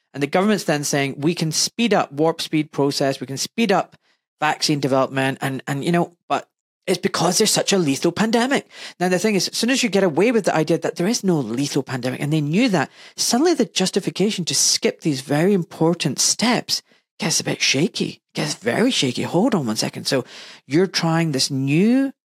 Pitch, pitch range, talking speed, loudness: 170 Hz, 145-195 Hz, 210 wpm, -20 LUFS